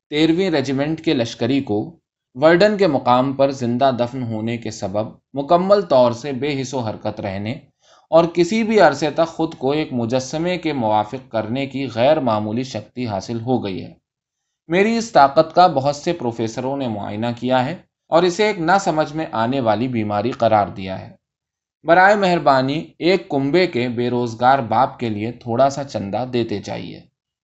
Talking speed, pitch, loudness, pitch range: 175 wpm, 130 Hz, -18 LUFS, 115-160 Hz